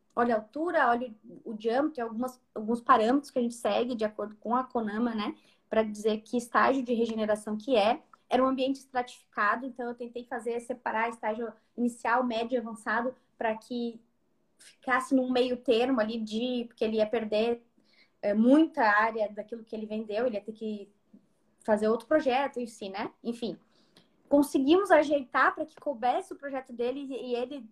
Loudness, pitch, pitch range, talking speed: -29 LUFS, 240 Hz, 220-255 Hz, 175 wpm